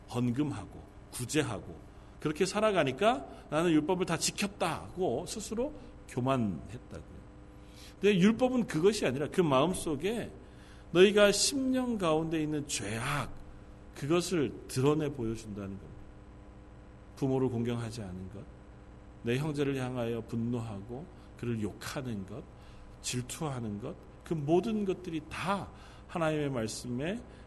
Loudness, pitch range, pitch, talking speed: -32 LUFS, 115-175 Hz, 140 Hz, 265 characters per minute